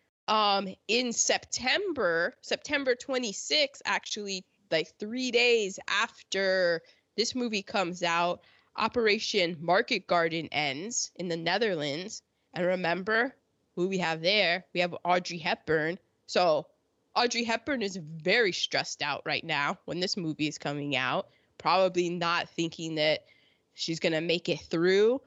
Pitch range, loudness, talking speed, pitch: 170-215 Hz, -29 LUFS, 135 wpm, 180 Hz